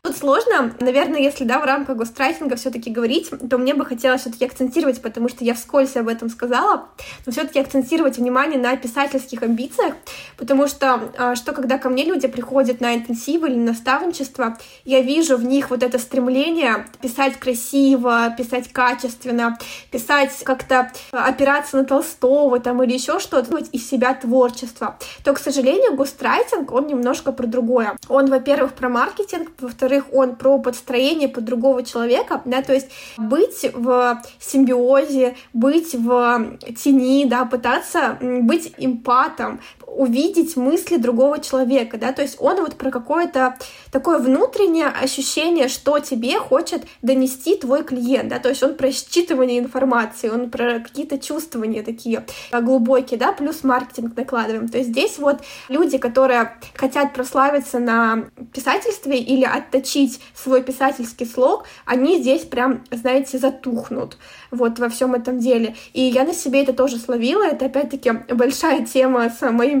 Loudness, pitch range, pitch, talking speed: -19 LUFS, 245-275 Hz, 260 Hz, 150 wpm